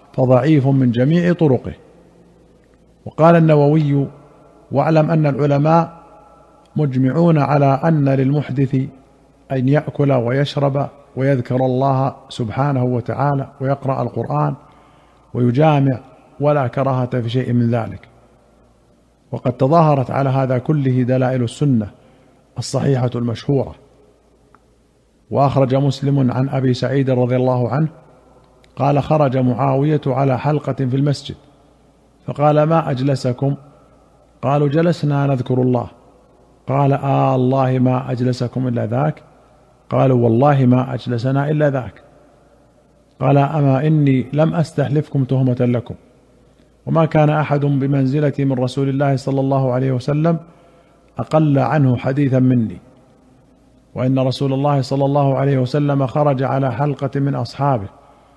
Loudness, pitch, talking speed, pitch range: -17 LUFS, 135 Hz, 110 wpm, 125-145 Hz